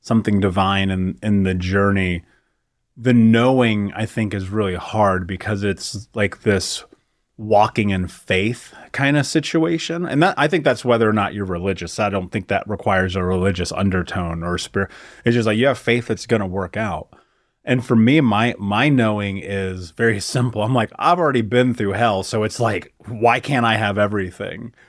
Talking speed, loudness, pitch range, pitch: 190 wpm, -19 LUFS, 95-120 Hz, 105 Hz